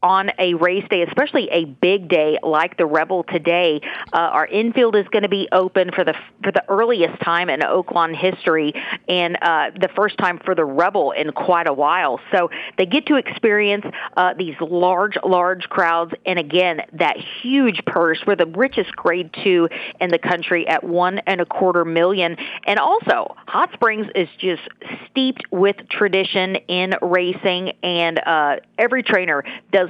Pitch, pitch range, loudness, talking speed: 185 Hz, 170-205 Hz, -18 LUFS, 175 wpm